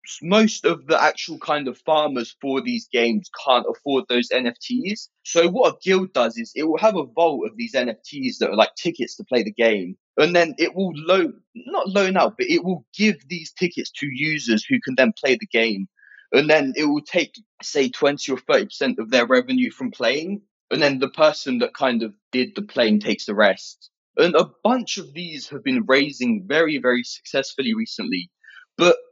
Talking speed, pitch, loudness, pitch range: 200 wpm, 175 Hz, -21 LUFS, 145-225 Hz